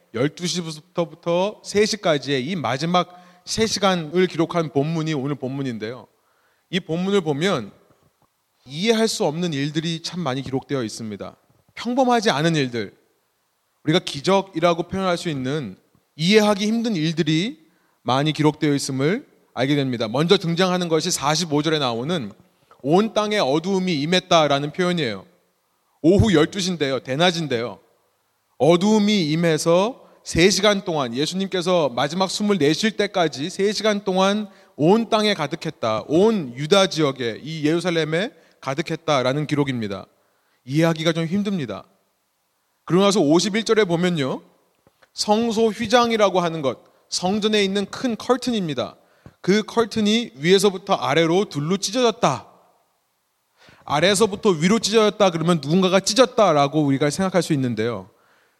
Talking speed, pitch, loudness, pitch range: 300 characters per minute, 175 Hz, -20 LUFS, 150-200 Hz